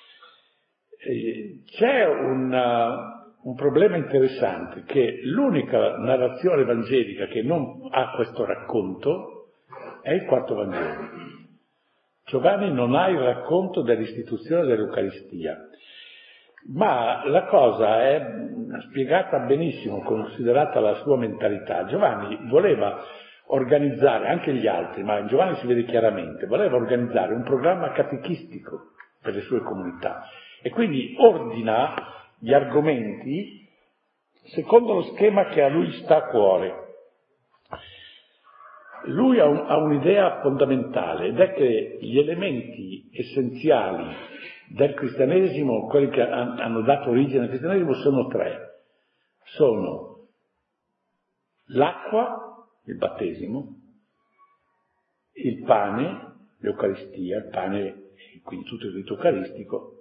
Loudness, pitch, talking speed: -23 LUFS, 150 Hz, 105 wpm